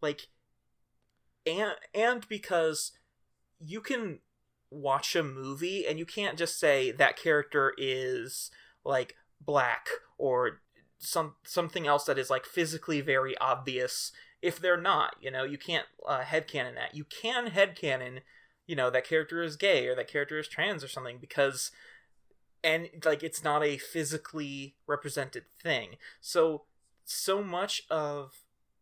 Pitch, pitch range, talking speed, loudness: 160 Hz, 145-200 Hz, 140 wpm, -31 LUFS